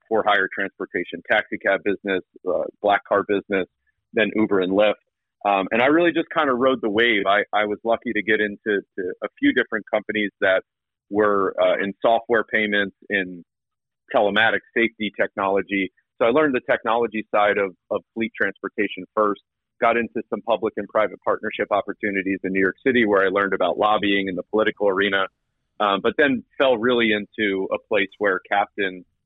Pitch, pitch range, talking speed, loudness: 105 Hz, 100-115 Hz, 180 wpm, -21 LUFS